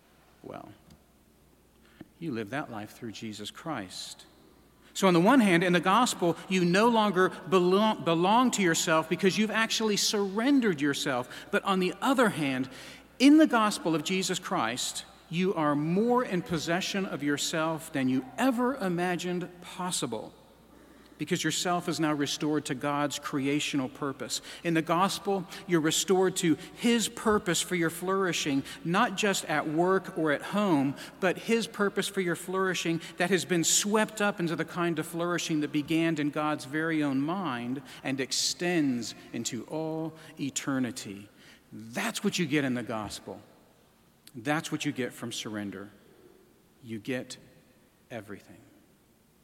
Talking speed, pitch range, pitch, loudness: 150 wpm, 145-190 Hz, 165 Hz, -28 LUFS